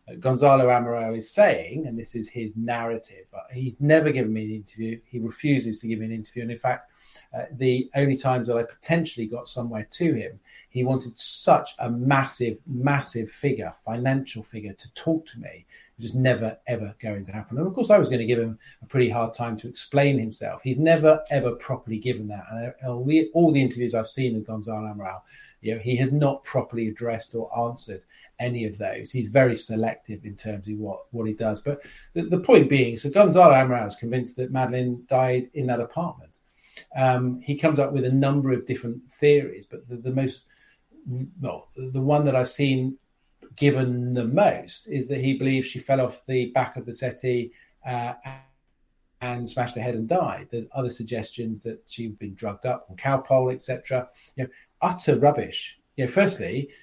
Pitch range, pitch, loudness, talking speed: 115-135 Hz, 125 Hz, -24 LUFS, 200 wpm